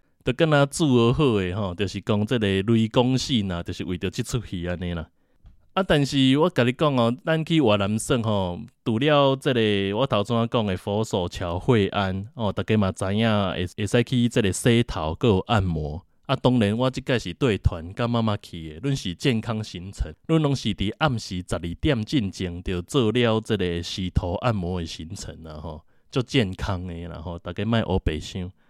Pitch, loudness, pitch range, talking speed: 105 Hz, -24 LUFS, 90-125 Hz, 280 characters per minute